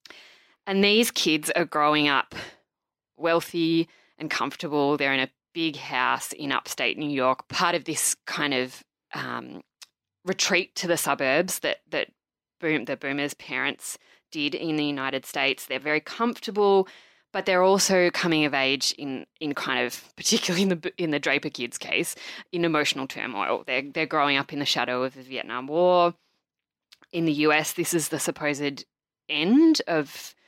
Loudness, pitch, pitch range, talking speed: -25 LUFS, 155 Hz, 145-180 Hz, 165 wpm